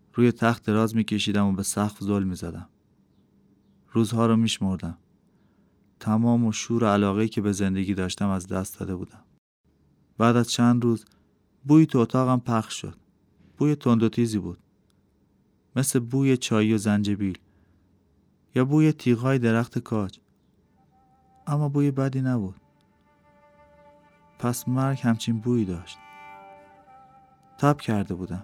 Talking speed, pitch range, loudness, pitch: 130 wpm, 100-125 Hz, -24 LUFS, 115 Hz